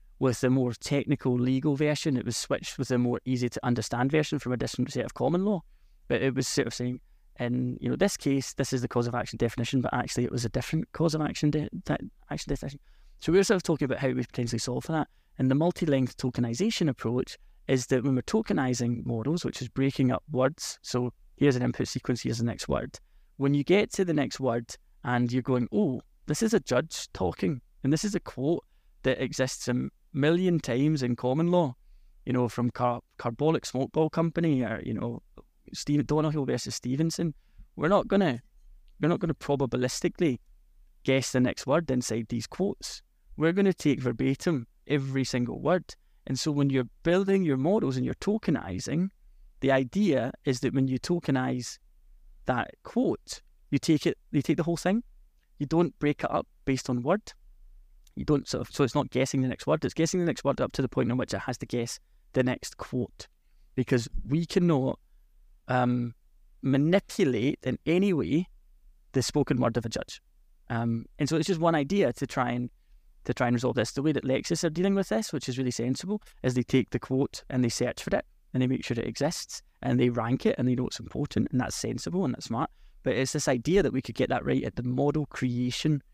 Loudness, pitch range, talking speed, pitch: -28 LUFS, 125-155 Hz, 215 wpm, 130 Hz